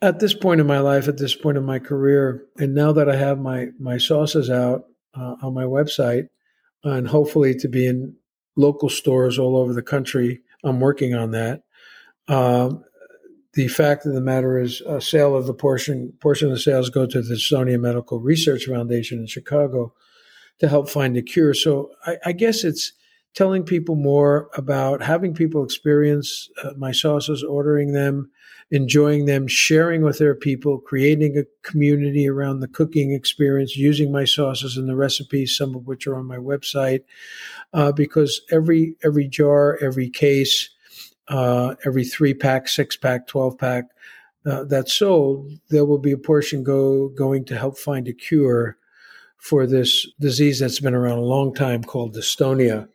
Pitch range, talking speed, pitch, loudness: 130-145 Hz, 175 wpm, 140 Hz, -20 LUFS